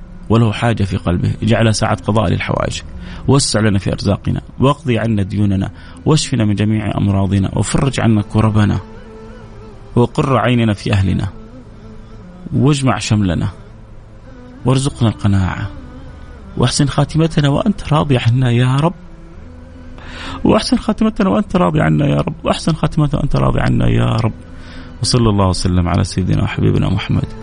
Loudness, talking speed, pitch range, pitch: -15 LUFS, 125 wpm, 95-125 Hz, 110 Hz